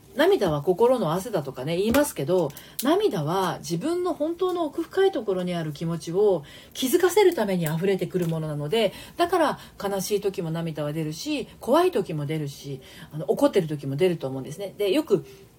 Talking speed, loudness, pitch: 360 characters per minute, -25 LUFS, 185 Hz